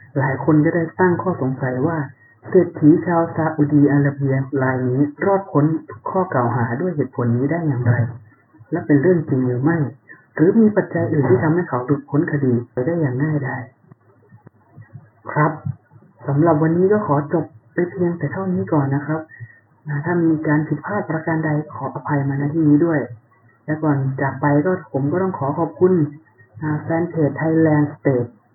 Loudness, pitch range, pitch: -19 LUFS, 130-165 Hz, 145 Hz